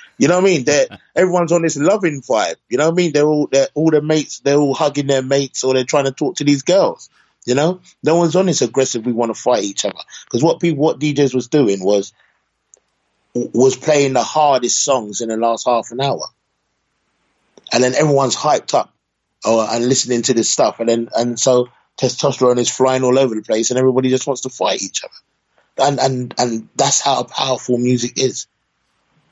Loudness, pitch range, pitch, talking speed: -16 LUFS, 120-150 Hz, 130 Hz, 215 wpm